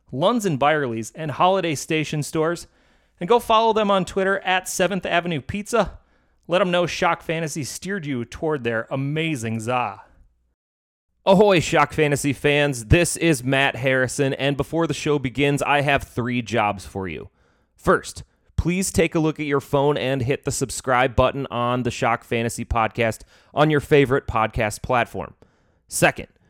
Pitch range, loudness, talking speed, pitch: 125-165 Hz, -21 LUFS, 160 wpm, 145 Hz